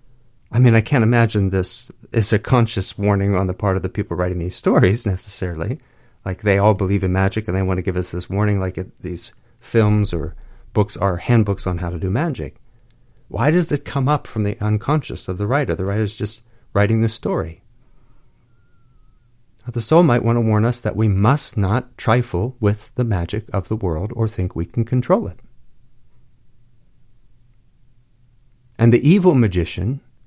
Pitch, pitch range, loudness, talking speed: 115 Hz, 95-120 Hz, -19 LUFS, 185 wpm